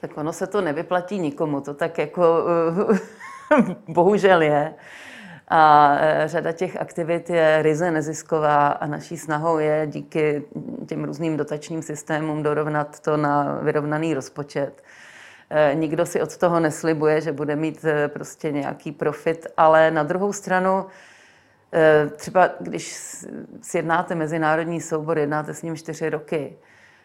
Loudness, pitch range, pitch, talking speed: -21 LUFS, 150-170 Hz, 160 Hz, 125 wpm